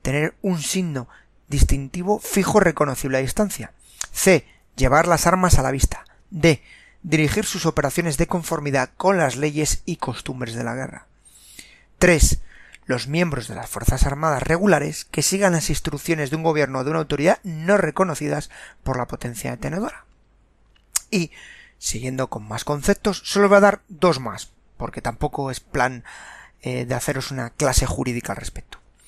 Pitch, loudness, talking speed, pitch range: 150 Hz, -21 LUFS, 160 wpm, 130-175 Hz